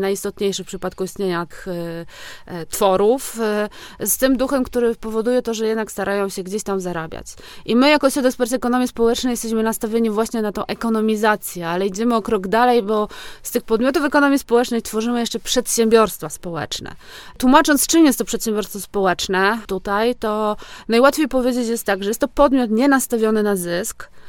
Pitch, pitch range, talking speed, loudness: 225 Hz, 200-245 Hz, 170 wpm, -19 LUFS